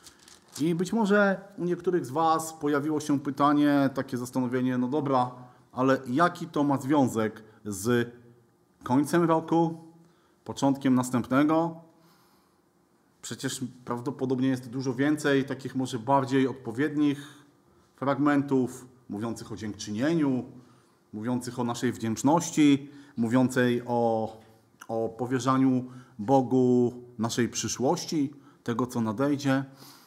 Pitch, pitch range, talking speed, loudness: 130 Hz, 120-145 Hz, 100 wpm, -27 LUFS